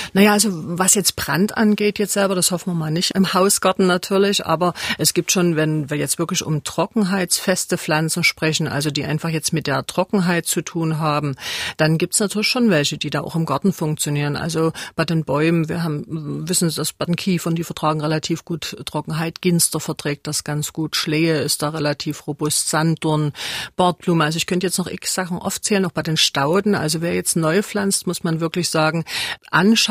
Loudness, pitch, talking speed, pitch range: -19 LUFS, 165 Hz, 205 wpm, 155-185 Hz